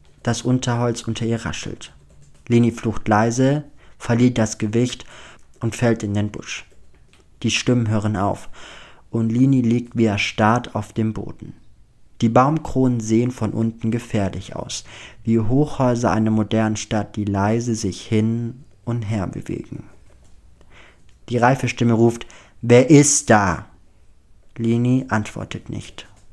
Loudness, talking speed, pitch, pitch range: -20 LUFS, 130 wpm, 115 Hz, 110-120 Hz